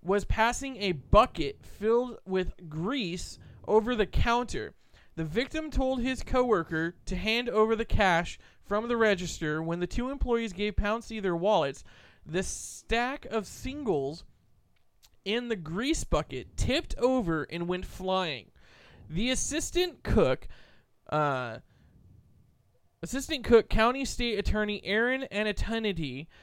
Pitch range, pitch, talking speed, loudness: 180-245 Hz, 215 Hz, 125 wpm, -29 LUFS